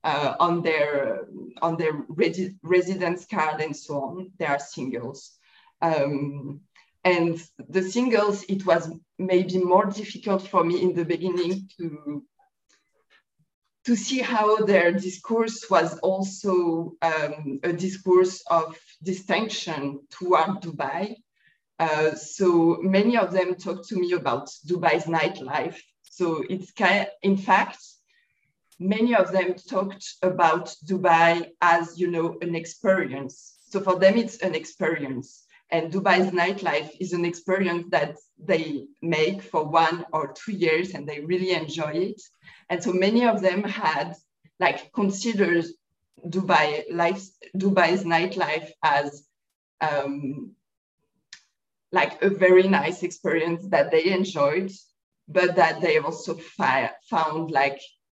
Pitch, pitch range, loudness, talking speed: 175 Hz, 155-190 Hz, -24 LUFS, 130 wpm